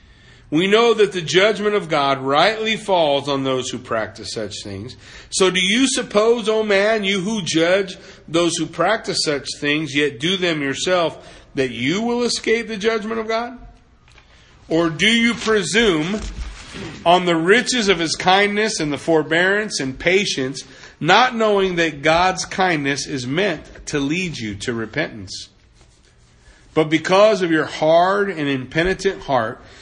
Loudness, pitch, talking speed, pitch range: -18 LUFS, 170 Hz, 155 wpm, 140-205 Hz